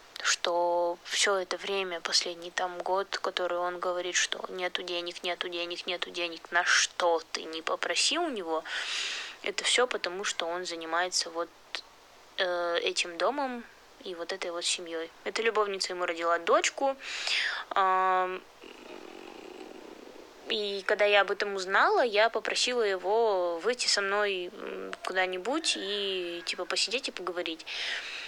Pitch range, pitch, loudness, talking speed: 175-215 Hz, 185 Hz, -29 LUFS, 135 wpm